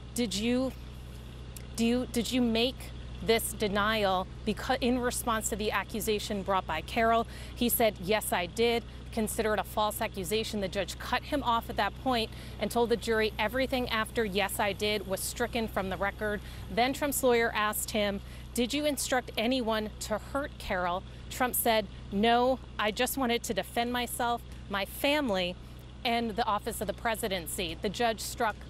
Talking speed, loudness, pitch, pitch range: 170 wpm, -30 LUFS, 225 Hz, 210-240 Hz